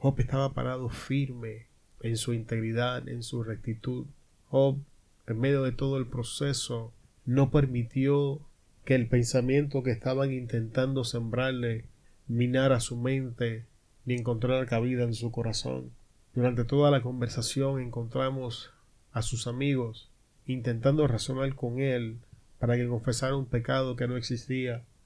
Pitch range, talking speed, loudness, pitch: 115-130 Hz, 130 wpm, -30 LUFS, 125 Hz